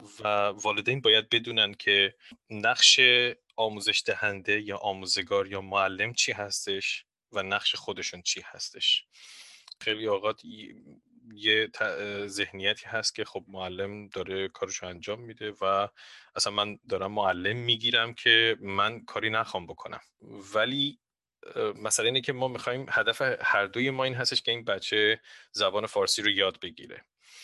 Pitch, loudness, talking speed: 110 Hz, -26 LUFS, 135 wpm